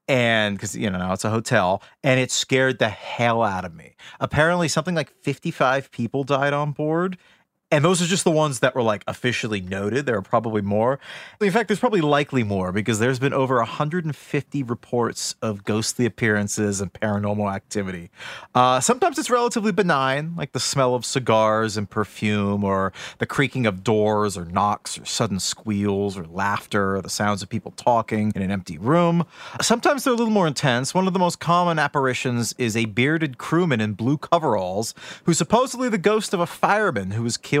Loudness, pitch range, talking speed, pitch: -22 LUFS, 105-155 Hz, 190 wpm, 125 Hz